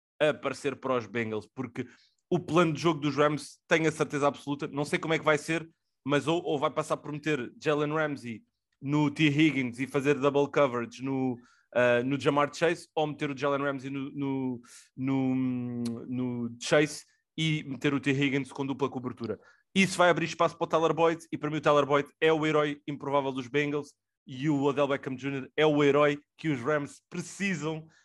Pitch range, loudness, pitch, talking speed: 135-155 Hz, -29 LUFS, 145 Hz, 200 wpm